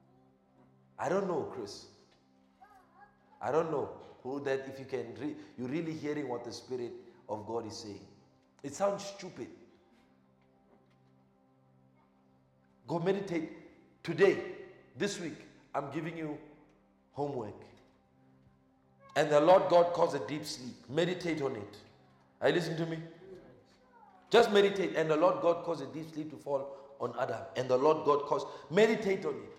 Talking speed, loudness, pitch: 150 wpm, -33 LUFS, 140 Hz